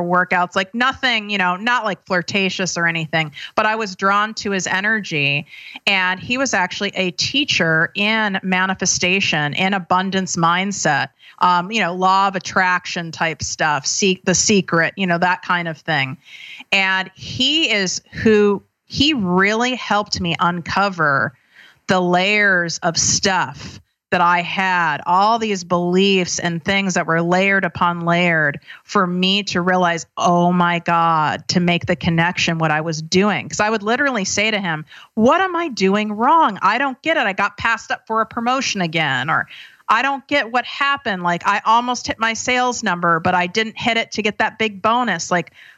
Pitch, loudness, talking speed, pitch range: 190 Hz, -17 LUFS, 175 wpm, 175-220 Hz